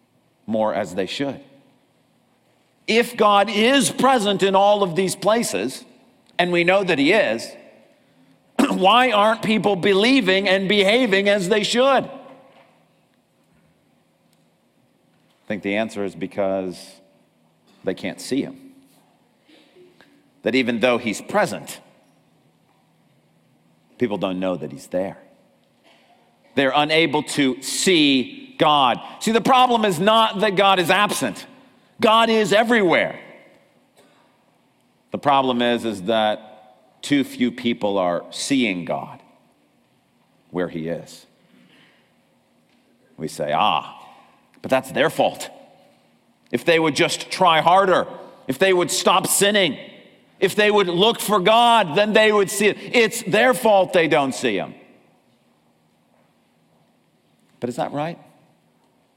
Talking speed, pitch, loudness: 120 wpm, 195 Hz, -19 LUFS